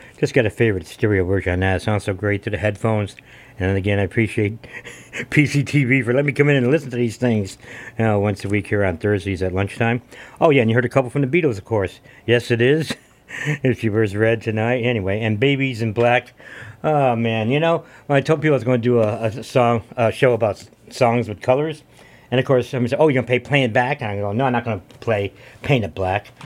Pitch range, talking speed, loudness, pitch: 105-130 Hz, 250 wpm, -19 LUFS, 120 Hz